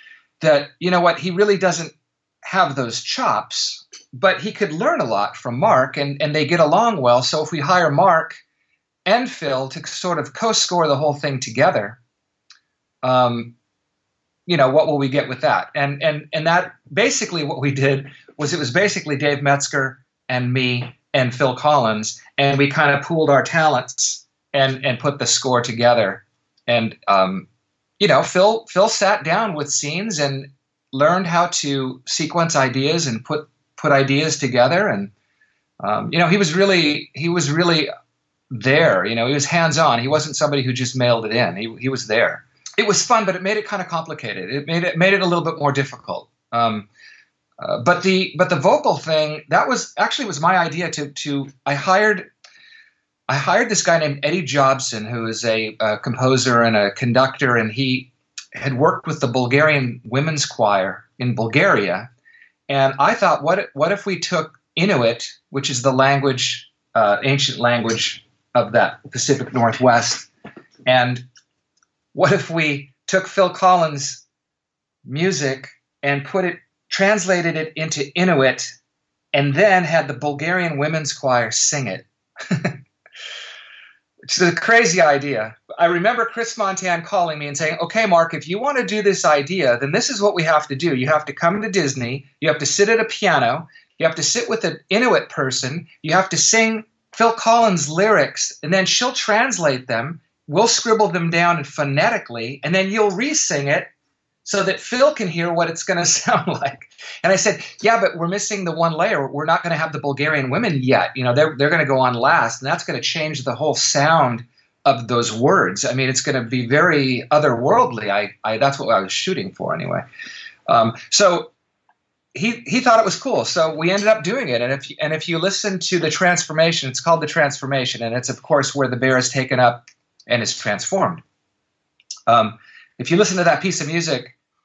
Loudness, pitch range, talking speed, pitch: -18 LUFS, 135-180 Hz, 190 wpm, 155 Hz